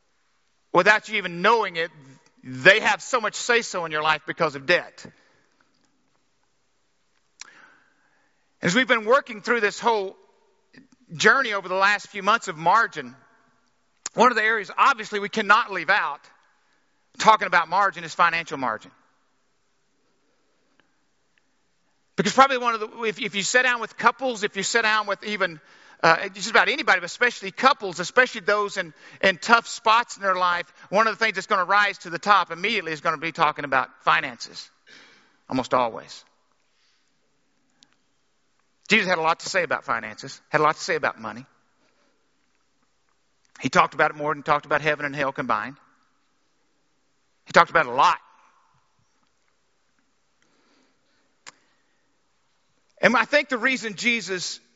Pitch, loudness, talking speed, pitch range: 195 Hz, -22 LUFS, 155 wpm, 165-225 Hz